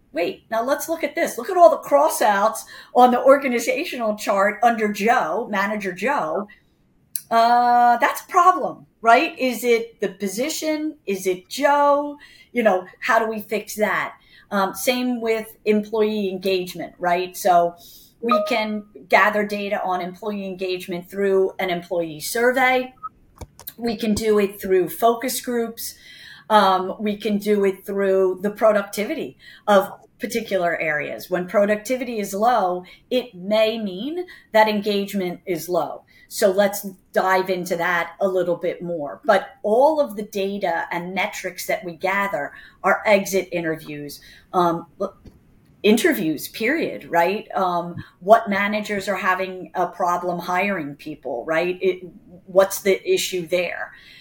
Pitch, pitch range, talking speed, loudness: 205 Hz, 185-230 Hz, 140 wpm, -21 LUFS